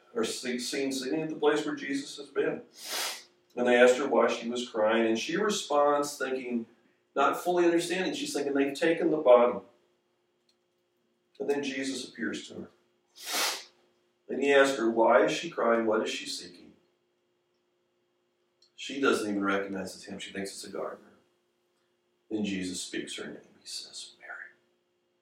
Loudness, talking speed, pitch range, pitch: -28 LUFS, 160 wpm, 100-145 Hz, 125 Hz